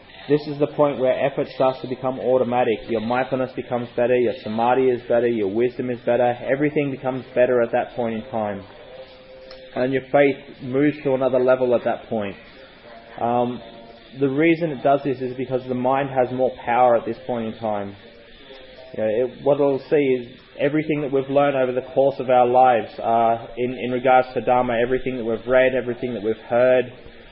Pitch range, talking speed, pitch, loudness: 120-130 Hz, 195 wpm, 125 Hz, -21 LUFS